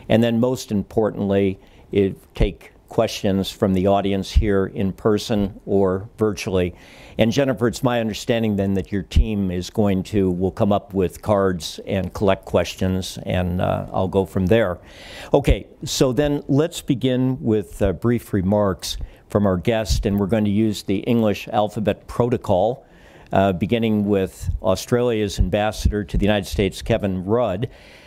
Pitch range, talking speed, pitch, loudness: 95-110 Hz, 155 wpm, 100 Hz, -21 LUFS